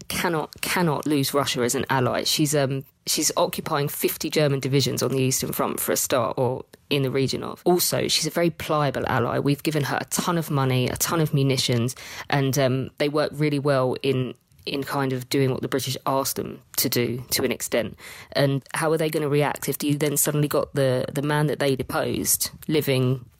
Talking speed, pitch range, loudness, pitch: 215 wpm, 130-150 Hz, -23 LUFS, 140 Hz